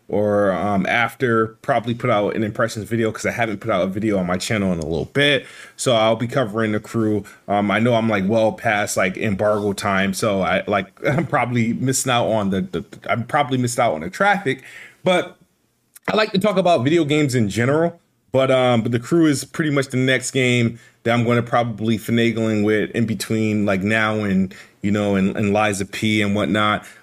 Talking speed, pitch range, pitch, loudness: 215 wpm, 105-130 Hz, 115 Hz, -19 LUFS